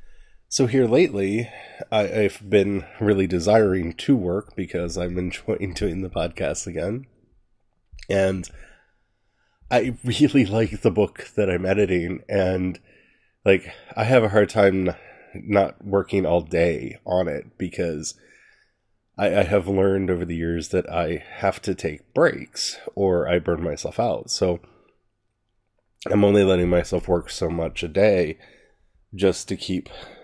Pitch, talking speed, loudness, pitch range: 95 Hz, 140 wpm, -22 LUFS, 90-105 Hz